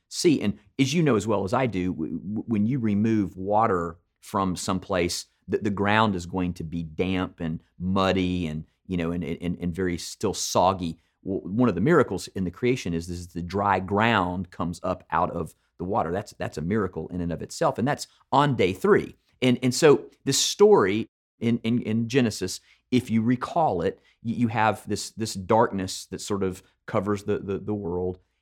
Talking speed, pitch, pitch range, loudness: 200 wpm, 95 Hz, 90-110 Hz, -25 LUFS